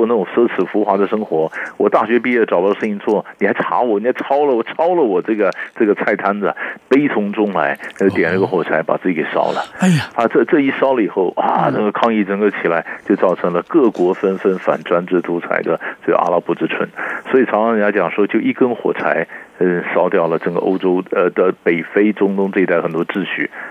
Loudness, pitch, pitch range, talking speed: -16 LUFS, 100 Hz, 90-105 Hz, 335 characters per minute